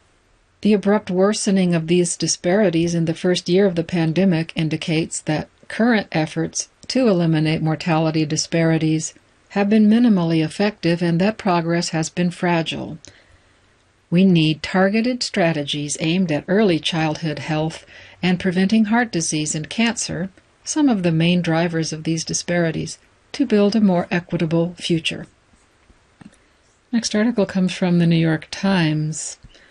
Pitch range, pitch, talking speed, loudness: 160-195 Hz, 170 Hz, 135 wpm, -19 LUFS